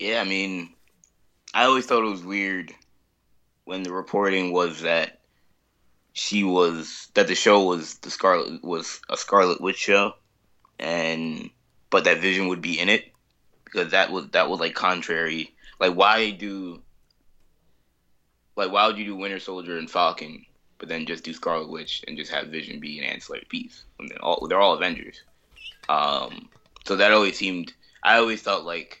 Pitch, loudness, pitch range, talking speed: 95 Hz, -23 LUFS, 85-100 Hz, 175 wpm